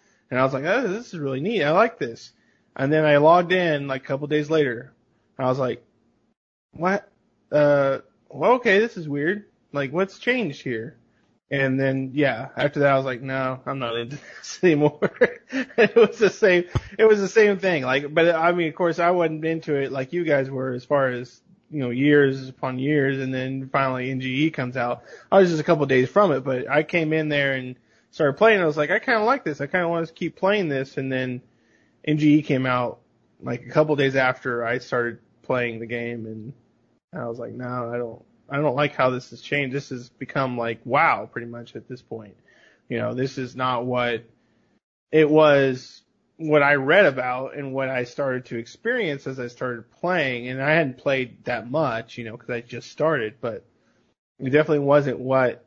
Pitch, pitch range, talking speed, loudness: 135 Hz, 125-155 Hz, 215 wpm, -22 LUFS